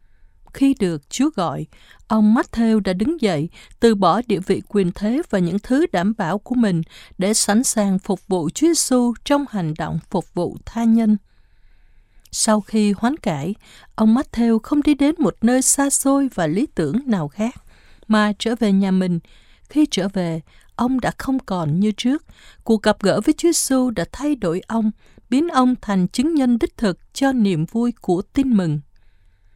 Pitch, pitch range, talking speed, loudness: 215 Hz, 180-250 Hz, 185 wpm, -19 LUFS